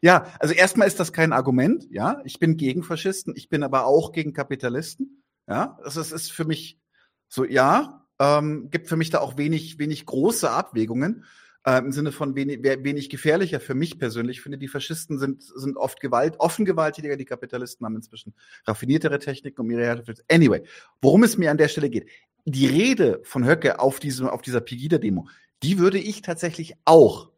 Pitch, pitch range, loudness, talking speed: 145 Hz, 130-165 Hz, -22 LUFS, 190 wpm